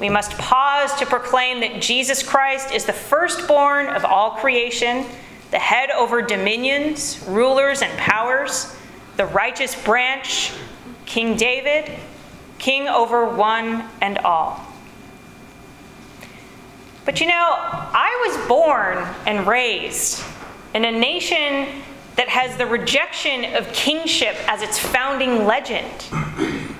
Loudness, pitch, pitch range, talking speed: -19 LUFS, 255 Hz, 230-280 Hz, 115 wpm